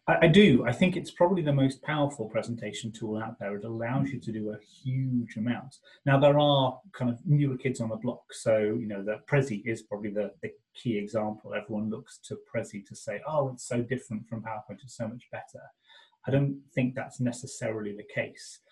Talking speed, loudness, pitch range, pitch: 210 wpm, -29 LUFS, 110-135 Hz, 120 Hz